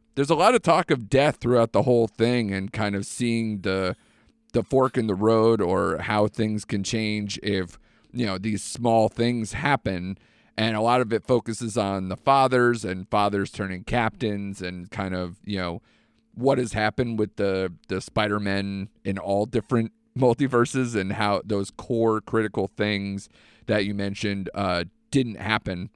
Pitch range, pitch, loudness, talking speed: 100-115 Hz, 110 Hz, -24 LUFS, 170 wpm